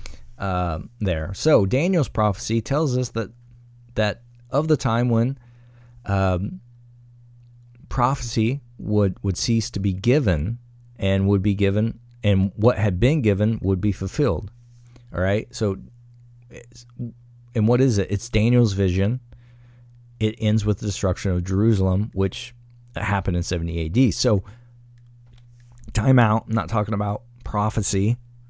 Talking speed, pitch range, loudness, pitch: 135 wpm, 100-120 Hz, -22 LUFS, 115 Hz